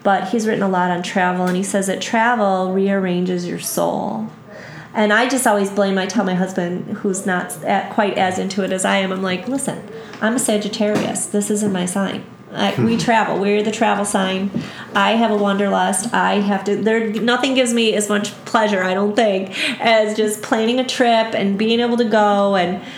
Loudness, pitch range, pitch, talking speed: -18 LUFS, 195-225 Hz, 205 Hz, 205 wpm